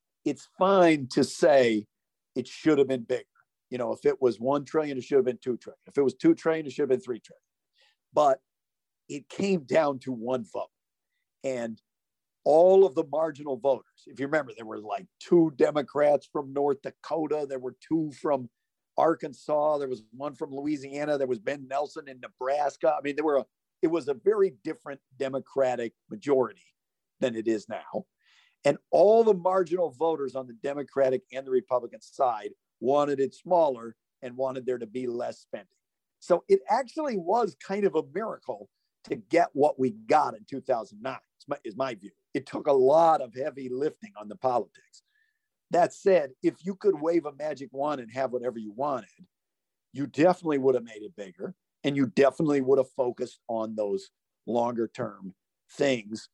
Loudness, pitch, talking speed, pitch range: -27 LUFS, 140 Hz, 185 wpm, 130-165 Hz